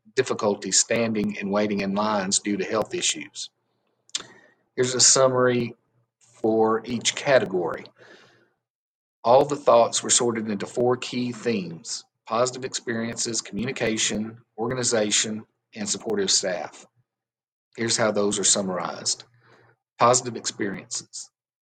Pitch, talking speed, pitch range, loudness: 115 Hz, 110 wpm, 110-120 Hz, -23 LUFS